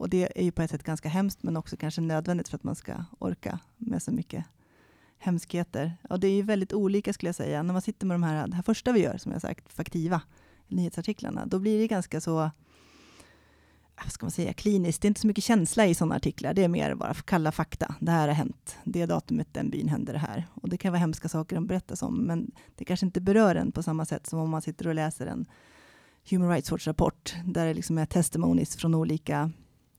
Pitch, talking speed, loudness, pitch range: 170 Hz, 235 wpm, -29 LUFS, 160-190 Hz